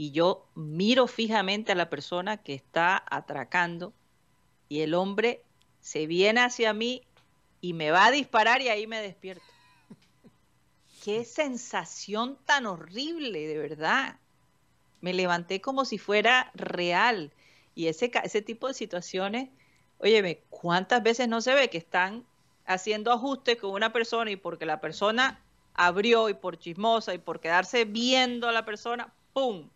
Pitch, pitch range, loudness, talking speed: 210 Hz, 175-235 Hz, -27 LUFS, 145 wpm